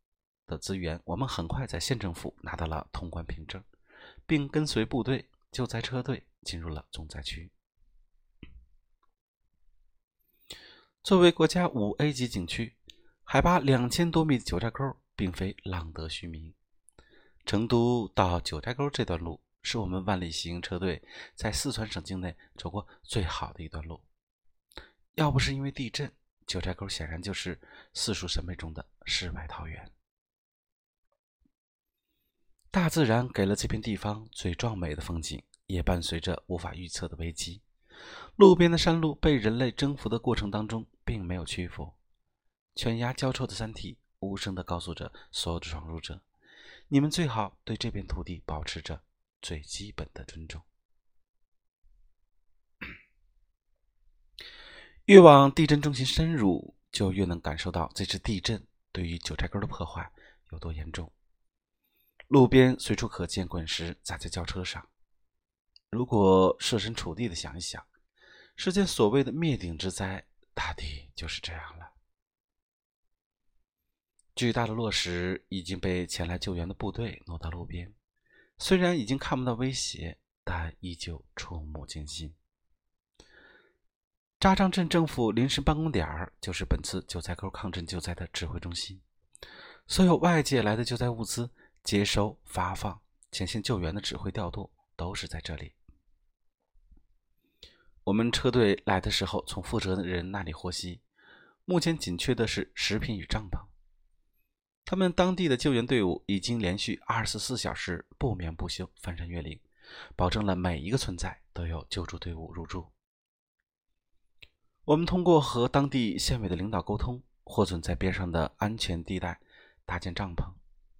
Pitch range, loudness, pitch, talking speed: 85-115 Hz, -29 LUFS, 95 Hz, 225 characters per minute